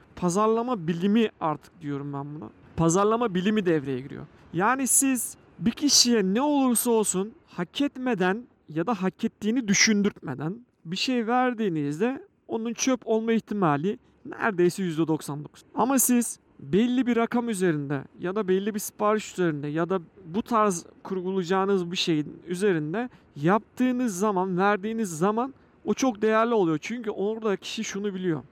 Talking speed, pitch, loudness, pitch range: 140 wpm, 205 Hz, -25 LUFS, 175-230 Hz